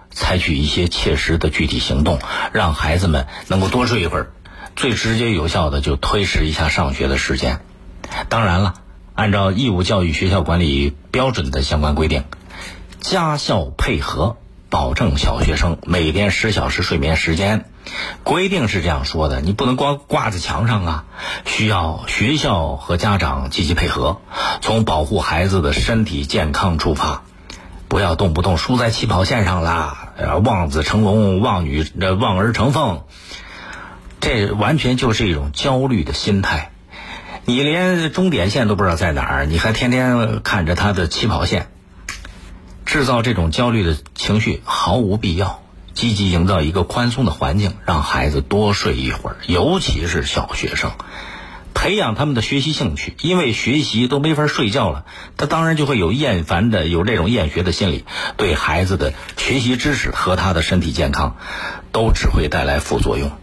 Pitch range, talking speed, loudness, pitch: 80-110 Hz, 255 characters per minute, -18 LUFS, 95 Hz